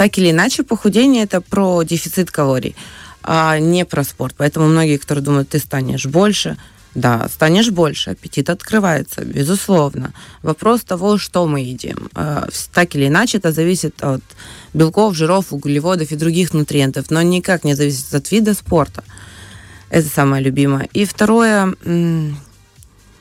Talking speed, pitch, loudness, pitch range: 140 wpm, 160 Hz, -15 LUFS, 140-185 Hz